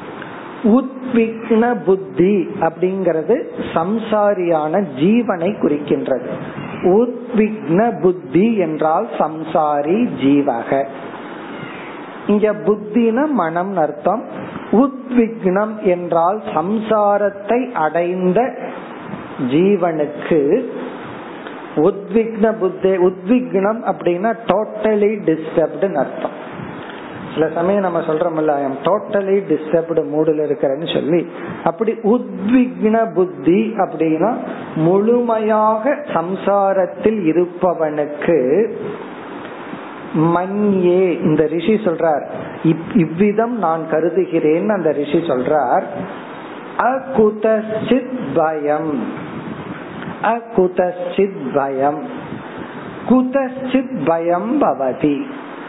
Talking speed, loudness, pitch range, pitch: 65 wpm, -17 LUFS, 165-220 Hz, 195 Hz